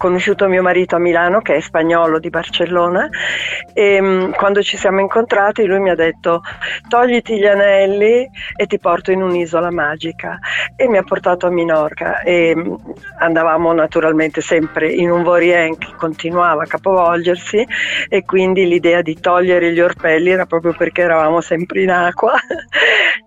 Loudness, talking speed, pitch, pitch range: -14 LUFS, 160 wpm, 175 Hz, 165-195 Hz